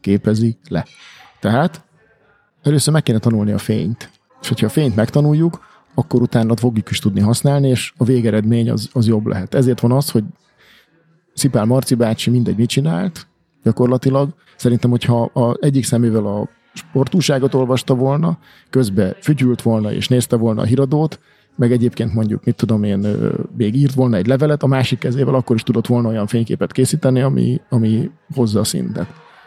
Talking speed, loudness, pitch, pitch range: 165 wpm, -17 LUFS, 125 Hz, 115-140 Hz